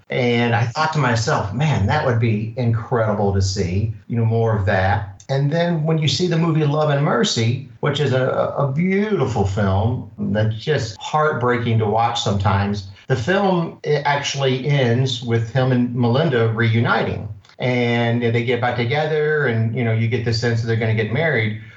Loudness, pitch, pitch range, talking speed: -19 LUFS, 120 Hz, 110-145 Hz, 185 wpm